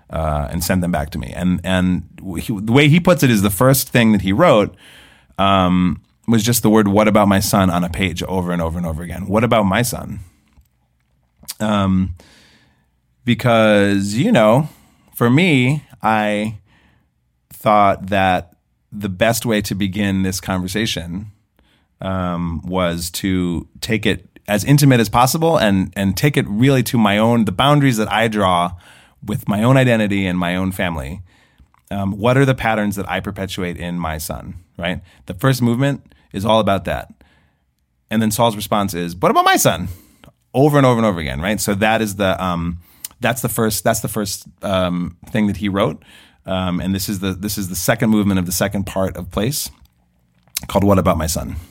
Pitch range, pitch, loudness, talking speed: 90-110 Hz, 100 Hz, -17 LUFS, 190 wpm